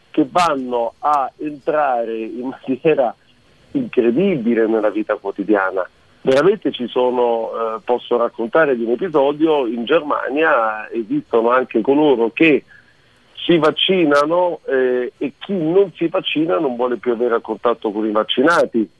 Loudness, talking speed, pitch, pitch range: -17 LUFS, 135 wpm, 125 Hz, 115-150 Hz